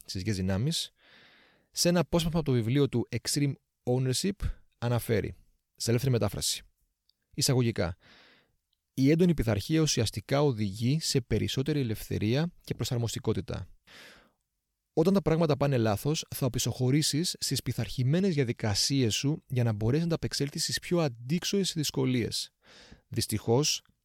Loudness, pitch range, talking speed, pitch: -29 LUFS, 110-150 Hz, 120 wpm, 125 Hz